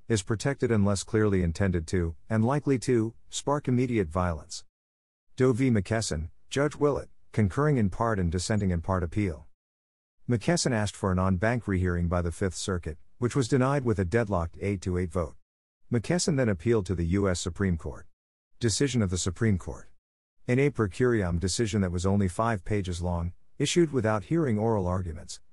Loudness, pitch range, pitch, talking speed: -28 LUFS, 90-120 Hz, 100 Hz, 170 wpm